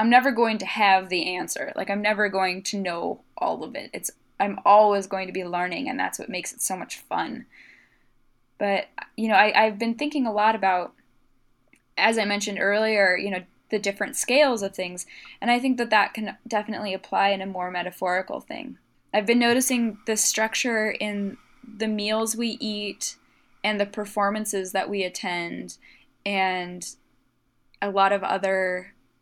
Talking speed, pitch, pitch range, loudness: 175 wpm, 205 Hz, 190-220 Hz, -24 LUFS